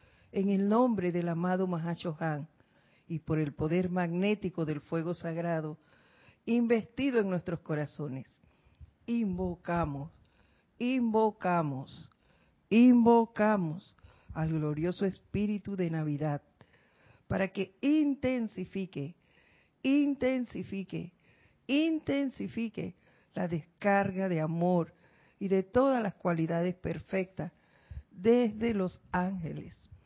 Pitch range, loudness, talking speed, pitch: 165-220 Hz, -31 LUFS, 90 wpm, 185 Hz